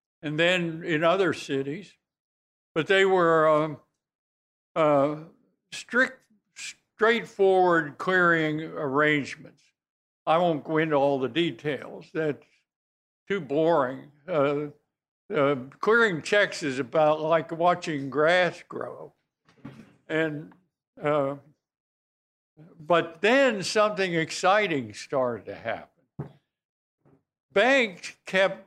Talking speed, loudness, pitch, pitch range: 95 wpm, -25 LUFS, 160 Hz, 145-185 Hz